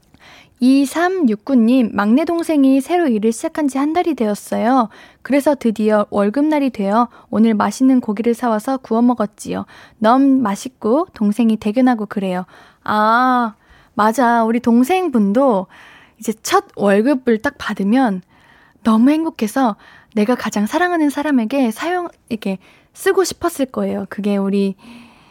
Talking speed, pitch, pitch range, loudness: 290 characters per minute, 240 Hz, 215-275 Hz, -16 LUFS